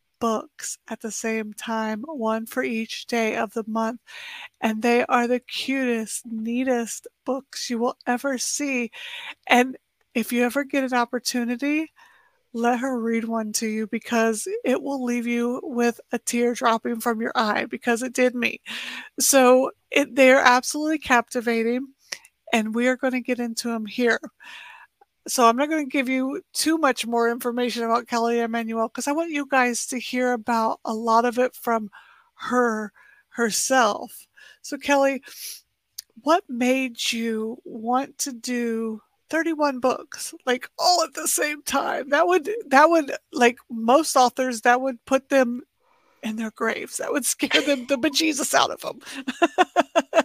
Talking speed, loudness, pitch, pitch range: 160 wpm, -23 LUFS, 250 Hz, 235-280 Hz